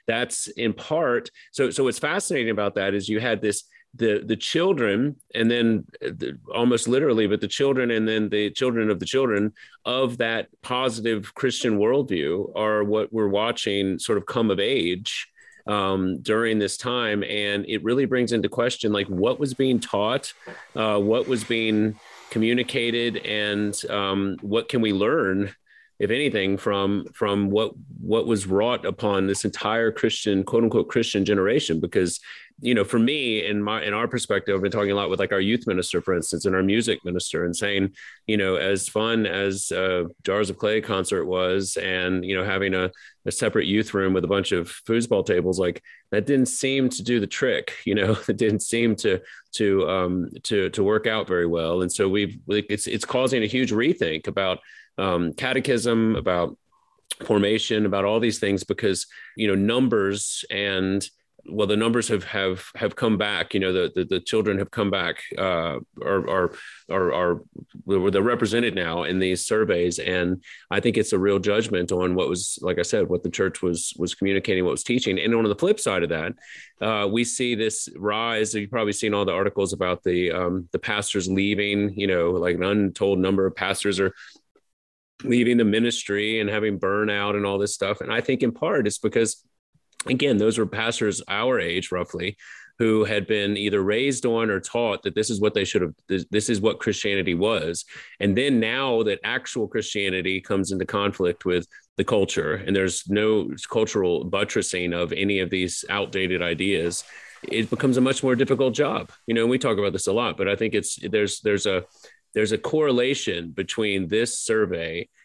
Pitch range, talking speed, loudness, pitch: 95-115 Hz, 190 wpm, -23 LUFS, 105 Hz